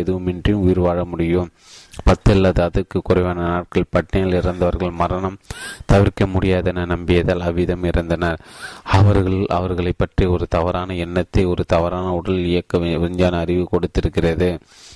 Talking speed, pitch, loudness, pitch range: 115 wpm, 90 Hz, -19 LUFS, 85-95 Hz